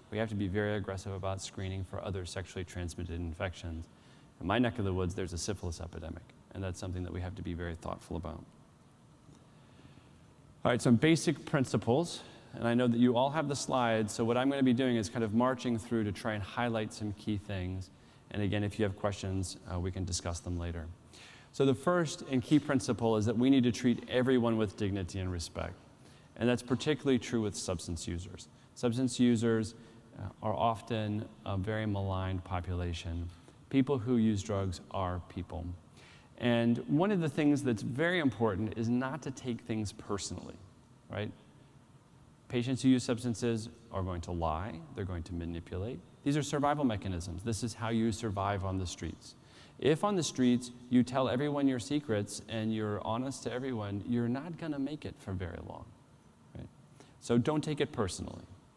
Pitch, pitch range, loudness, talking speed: 110 Hz, 95-125 Hz, -33 LUFS, 190 wpm